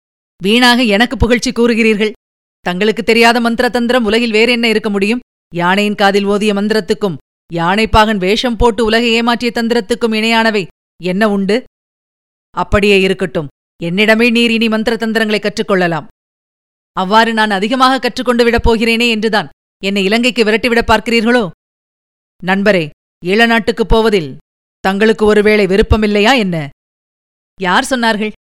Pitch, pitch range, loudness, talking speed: 220 Hz, 200-235 Hz, -12 LUFS, 115 wpm